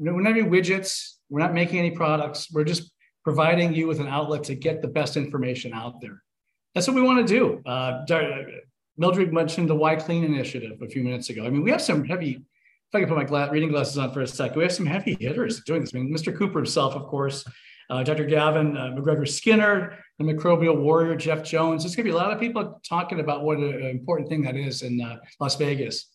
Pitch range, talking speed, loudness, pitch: 140-170 Hz, 240 wpm, -24 LUFS, 155 Hz